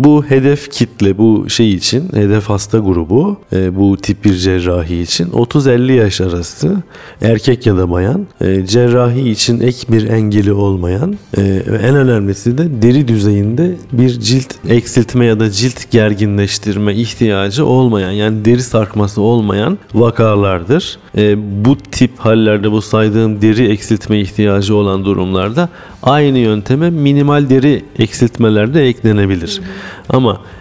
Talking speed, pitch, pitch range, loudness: 125 wpm, 110 Hz, 100-125 Hz, -12 LUFS